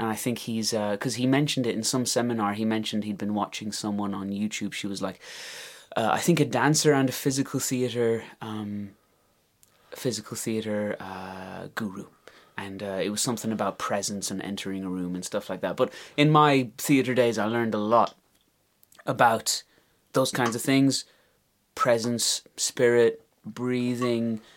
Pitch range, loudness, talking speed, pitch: 100-125 Hz, -26 LUFS, 170 wpm, 110 Hz